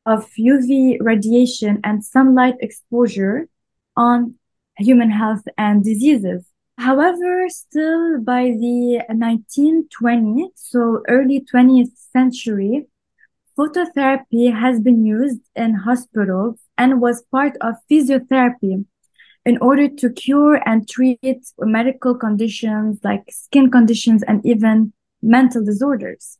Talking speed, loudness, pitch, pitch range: 105 wpm, -16 LUFS, 245 Hz, 225-265 Hz